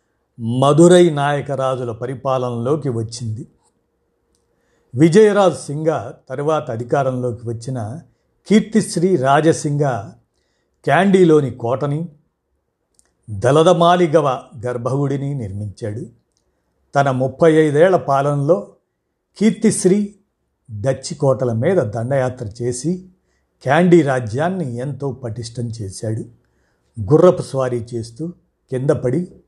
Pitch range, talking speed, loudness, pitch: 120-170 Hz, 75 wpm, -17 LUFS, 135 Hz